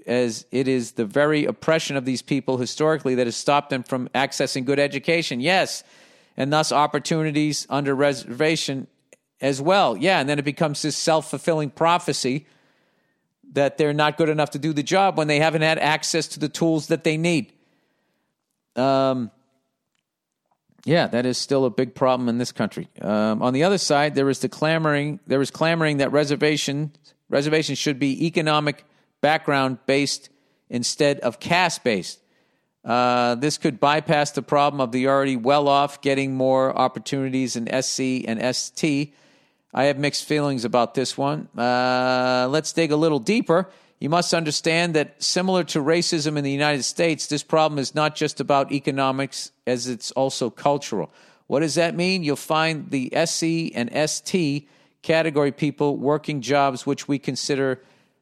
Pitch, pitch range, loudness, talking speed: 145 Hz, 130-155 Hz, -22 LUFS, 160 wpm